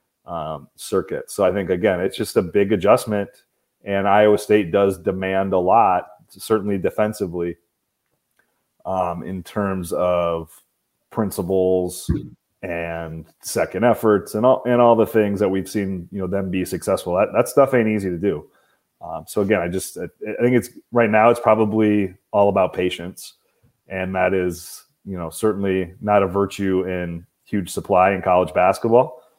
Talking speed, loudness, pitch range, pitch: 160 wpm, -20 LUFS, 90-105 Hz, 95 Hz